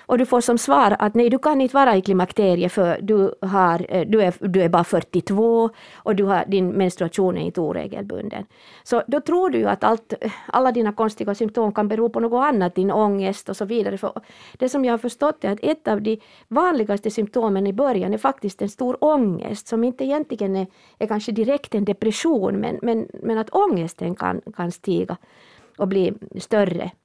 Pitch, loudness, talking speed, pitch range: 215 Hz, -21 LUFS, 200 wpm, 195-240 Hz